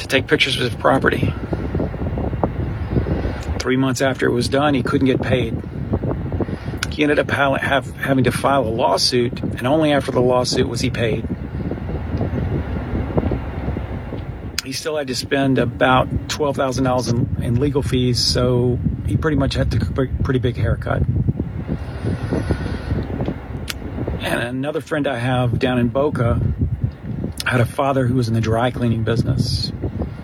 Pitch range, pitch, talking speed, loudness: 110-135 Hz, 125 Hz, 145 wpm, -20 LUFS